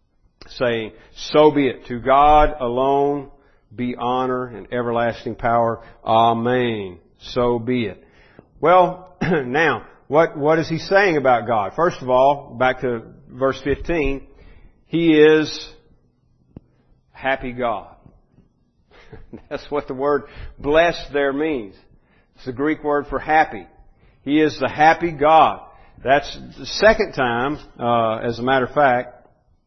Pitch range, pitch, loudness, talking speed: 120-150 Hz, 135 Hz, -19 LUFS, 130 wpm